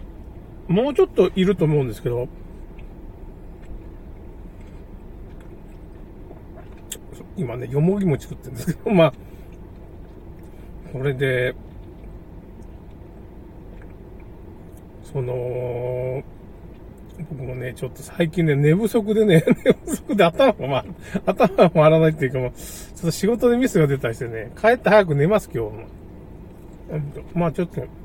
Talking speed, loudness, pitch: 215 characters per minute, -20 LUFS, 125 Hz